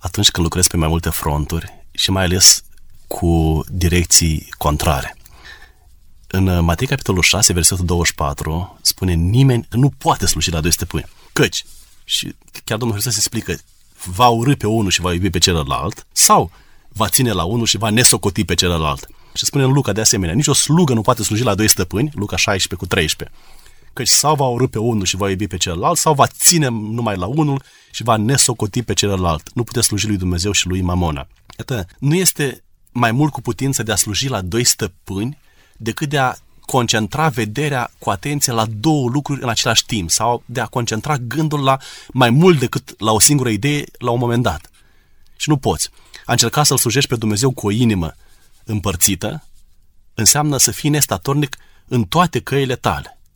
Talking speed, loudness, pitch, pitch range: 185 wpm, -16 LUFS, 110 Hz, 90-125 Hz